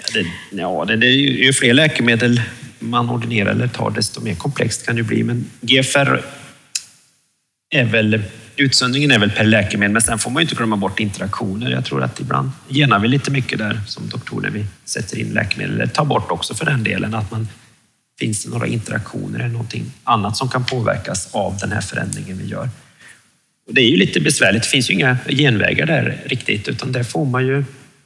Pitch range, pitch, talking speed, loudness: 110-130 Hz, 120 Hz, 195 wpm, -17 LUFS